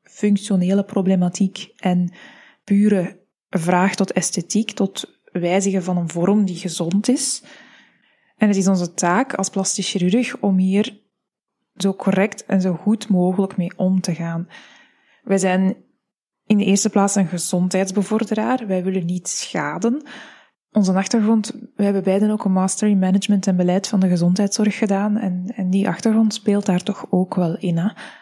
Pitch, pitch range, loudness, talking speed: 195 Hz, 185-215 Hz, -19 LUFS, 155 wpm